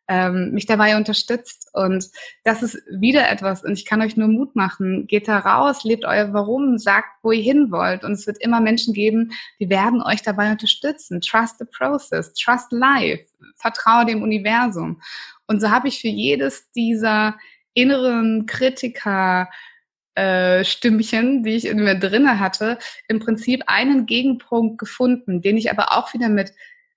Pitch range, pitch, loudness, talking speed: 205-245 Hz, 225 Hz, -19 LUFS, 160 wpm